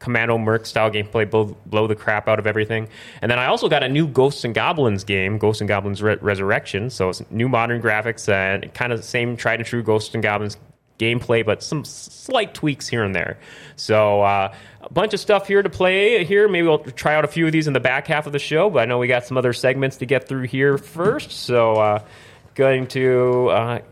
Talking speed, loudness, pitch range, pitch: 235 wpm, -19 LUFS, 110-140 Hz, 120 Hz